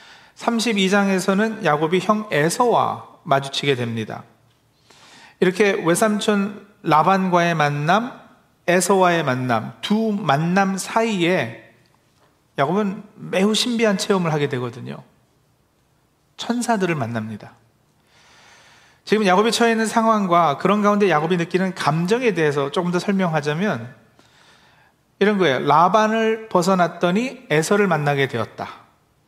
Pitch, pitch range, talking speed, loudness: 180 Hz, 145-210 Hz, 260 characters per minute, -19 LUFS